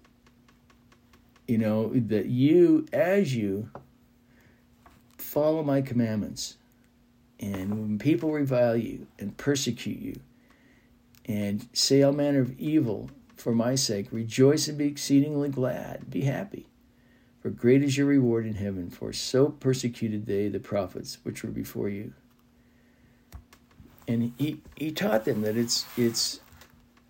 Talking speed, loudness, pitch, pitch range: 130 wpm, -27 LUFS, 120 Hz, 115-140 Hz